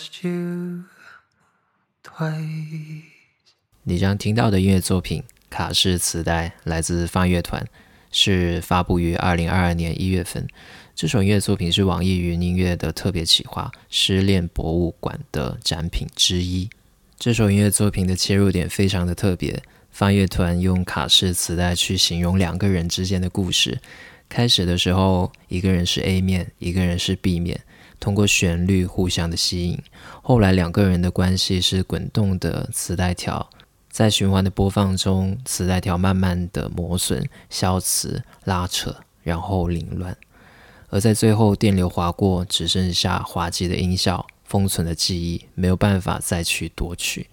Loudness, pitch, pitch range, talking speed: -21 LUFS, 95 Hz, 85-100 Hz, 235 characters per minute